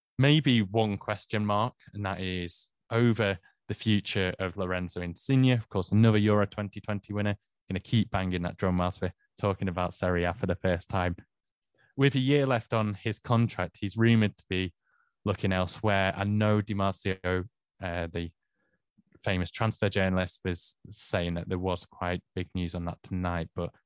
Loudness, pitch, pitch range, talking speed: -29 LUFS, 95 Hz, 90-110 Hz, 170 wpm